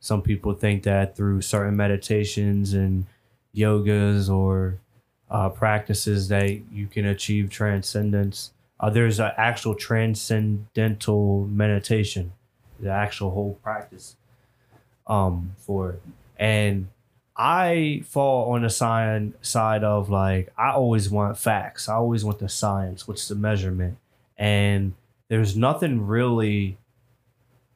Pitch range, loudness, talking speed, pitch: 100-115 Hz, -24 LUFS, 120 wpm, 105 Hz